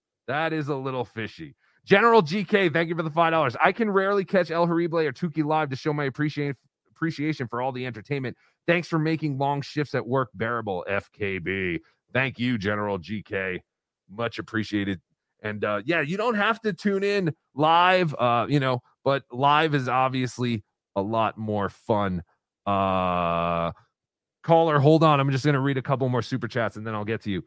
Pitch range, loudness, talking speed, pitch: 115-160 Hz, -25 LUFS, 190 wpm, 140 Hz